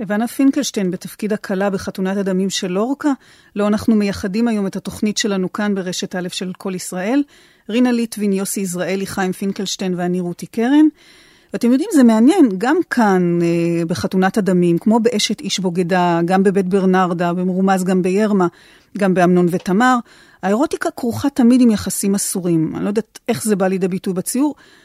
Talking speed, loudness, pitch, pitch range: 160 wpm, -17 LUFS, 200 Hz, 185-235 Hz